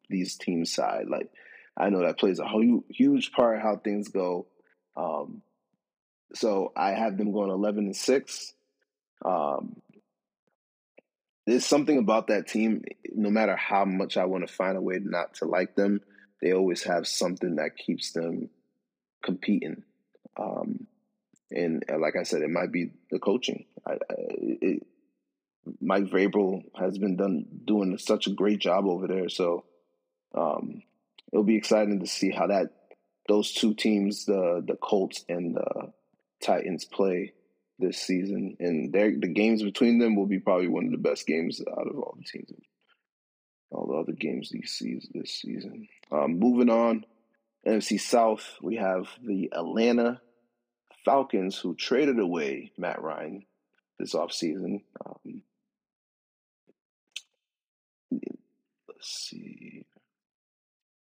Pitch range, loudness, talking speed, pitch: 95-120 Hz, -28 LUFS, 140 wpm, 105 Hz